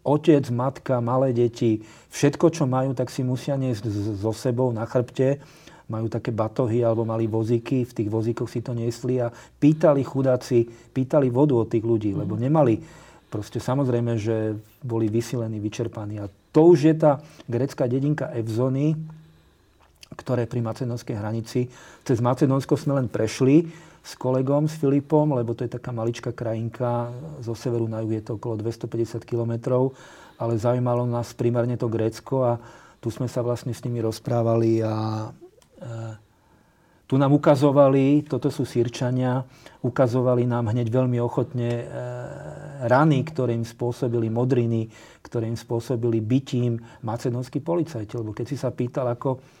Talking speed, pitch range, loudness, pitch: 150 wpm, 115-135 Hz, -24 LUFS, 120 Hz